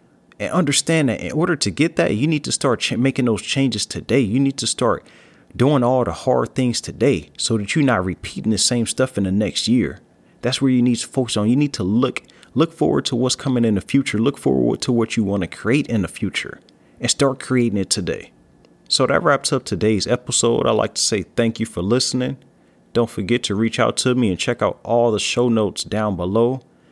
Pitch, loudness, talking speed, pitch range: 115 Hz, -19 LUFS, 230 wpm, 100-130 Hz